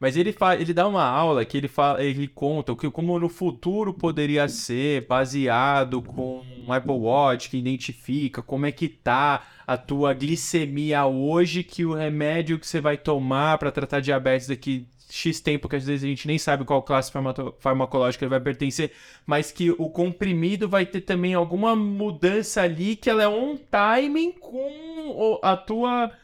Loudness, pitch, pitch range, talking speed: -24 LUFS, 150 Hz, 135-180 Hz, 180 wpm